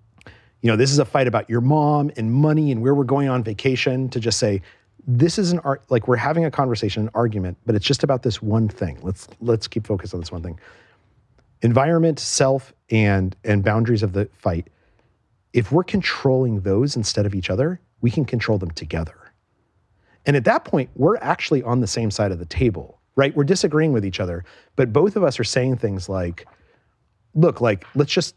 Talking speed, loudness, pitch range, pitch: 205 wpm, -20 LUFS, 105-135 Hz, 115 Hz